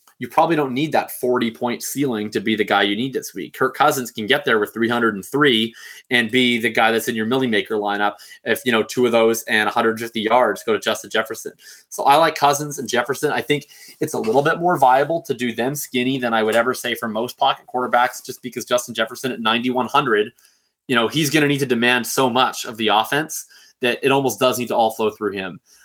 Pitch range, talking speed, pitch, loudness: 115-130 Hz, 235 wpm, 120 Hz, -19 LUFS